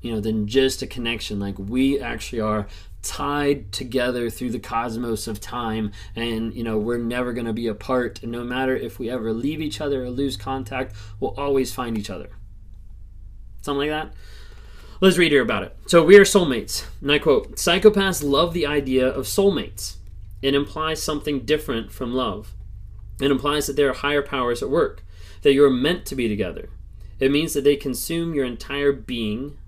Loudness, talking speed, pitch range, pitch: -22 LUFS, 185 wpm, 105-140 Hz, 125 Hz